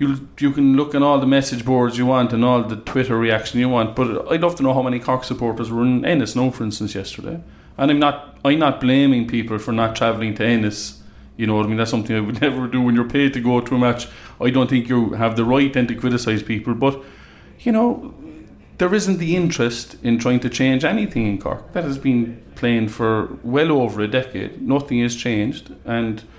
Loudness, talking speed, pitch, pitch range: -19 LUFS, 235 wpm, 125 Hz, 115-135 Hz